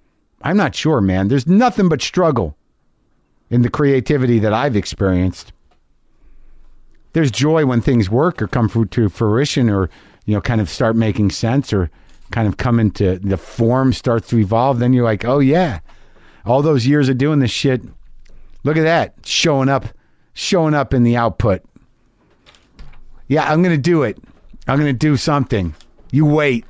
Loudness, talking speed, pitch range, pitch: -16 LUFS, 165 wpm, 105-145 Hz, 120 Hz